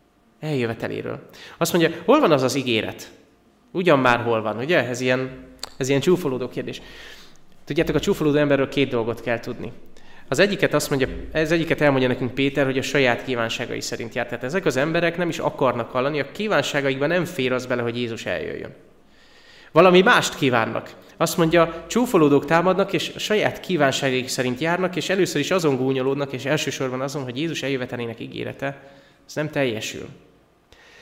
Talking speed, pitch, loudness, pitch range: 170 wpm, 140 Hz, -21 LUFS, 125-160 Hz